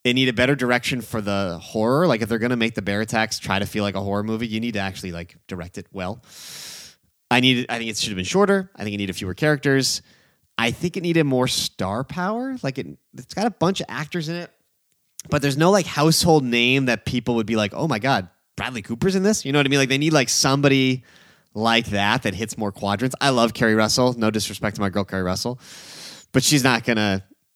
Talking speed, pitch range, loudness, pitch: 250 wpm, 105-140 Hz, -21 LUFS, 120 Hz